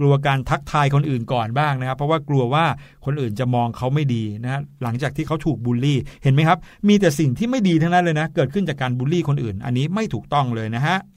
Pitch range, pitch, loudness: 125-160 Hz, 140 Hz, -20 LUFS